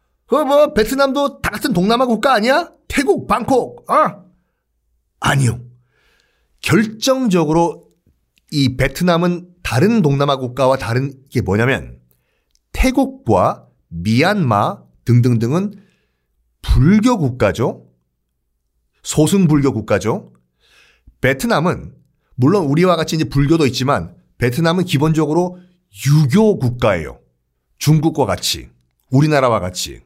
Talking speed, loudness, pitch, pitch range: 235 characters per minute, -16 LUFS, 140 Hz, 110-180 Hz